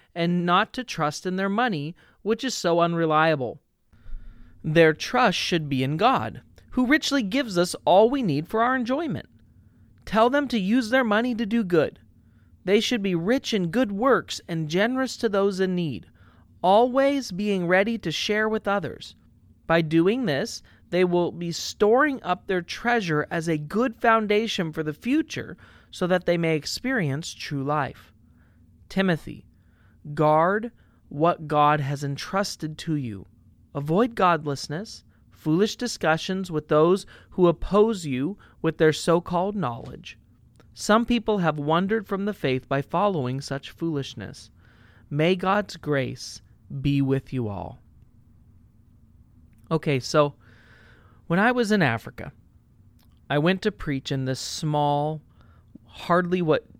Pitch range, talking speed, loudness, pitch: 140-205 Hz, 145 wpm, -24 LUFS, 165 Hz